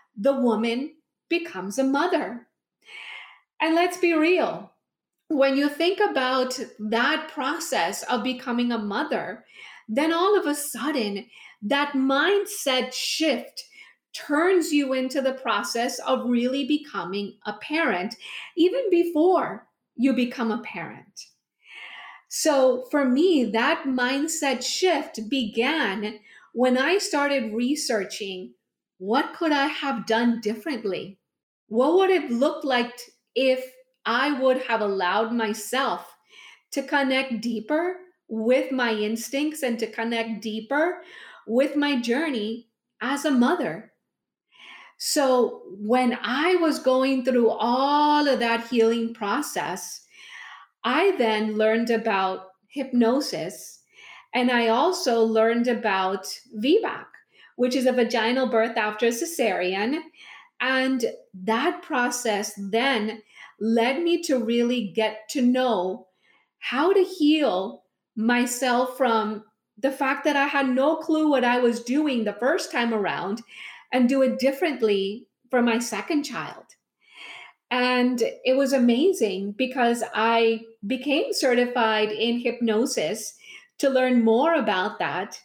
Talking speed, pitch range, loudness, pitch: 120 wpm, 225-290 Hz, -24 LUFS, 255 Hz